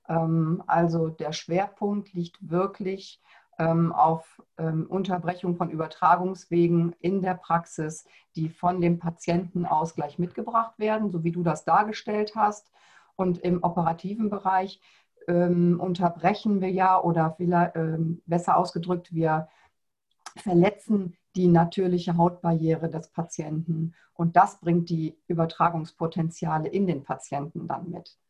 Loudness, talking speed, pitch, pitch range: -26 LUFS, 110 wpm, 175 Hz, 165-185 Hz